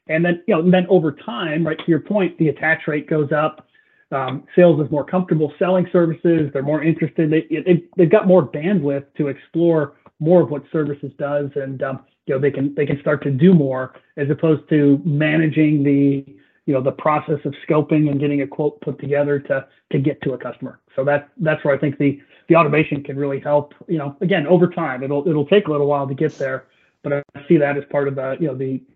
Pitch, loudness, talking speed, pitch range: 150 Hz, -19 LUFS, 230 wpm, 140-165 Hz